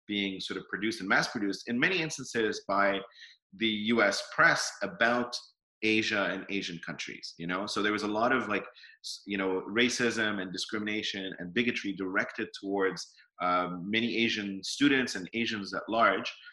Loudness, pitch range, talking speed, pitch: -30 LUFS, 95-115 Hz, 165 wpm, 105 Hz